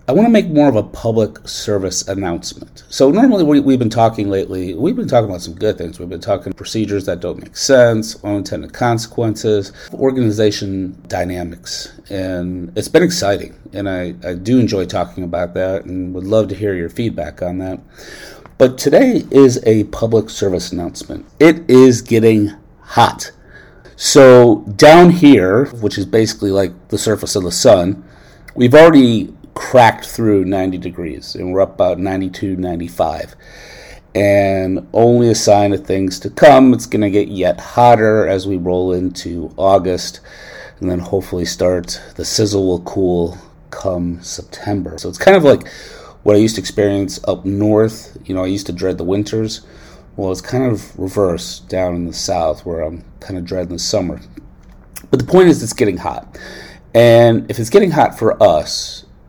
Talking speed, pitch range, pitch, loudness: 175 wpm, 90-110 Hz, 100 Hz, -14 LUFS